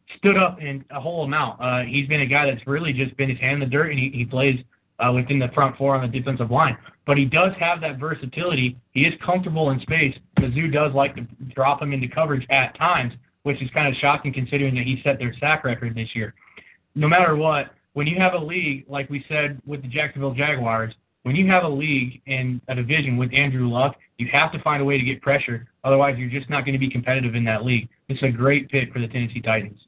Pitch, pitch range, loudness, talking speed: 135 Hz, 125-150 Hz, -21 LUFS, 245 wpm